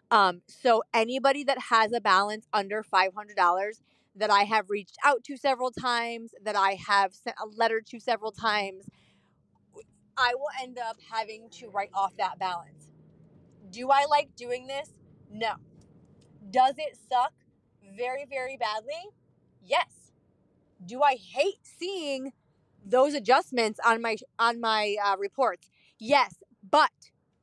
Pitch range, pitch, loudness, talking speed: 200-260 Hz, 230 Hz, -27 LUFS, 140 wpm